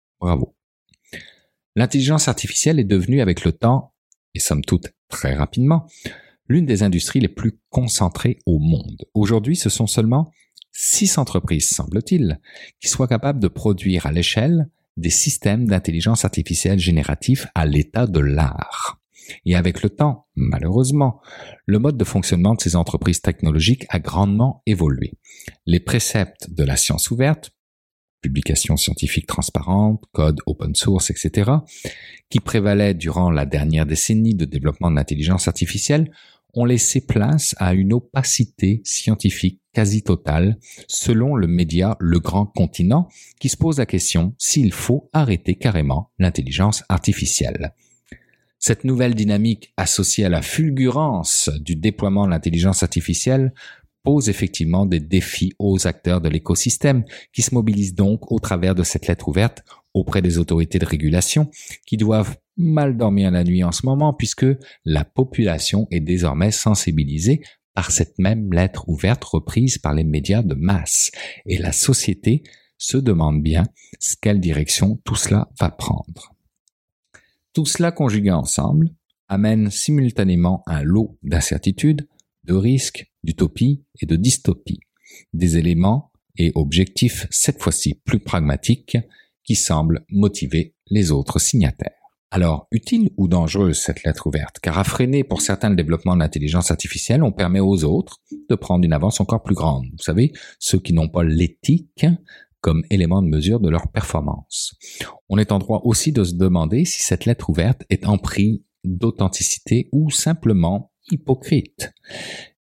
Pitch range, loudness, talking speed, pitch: 85-125 Hz, -19 LUFS, 145 wpm, 100 Hz